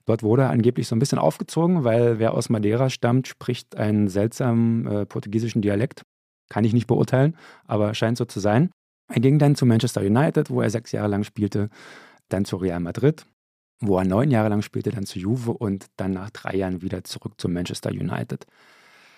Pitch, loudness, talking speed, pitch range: 115 Hz, -23 LUFS, 195 wpm, 100-125 Hz